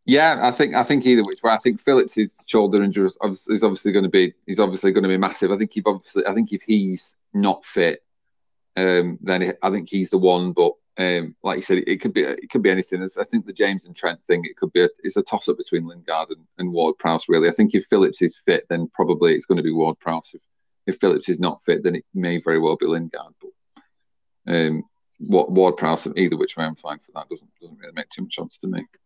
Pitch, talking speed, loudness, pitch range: 95 Hz, 245 wpm, -20 LUFS, 85-110 Hz